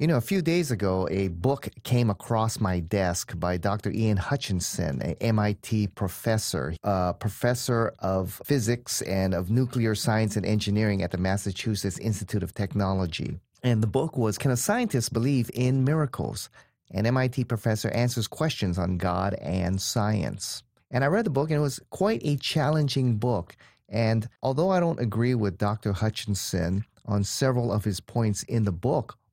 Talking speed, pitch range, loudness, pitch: 170 wpm, 100-125 Hz, -27 LUFS, 110 Hz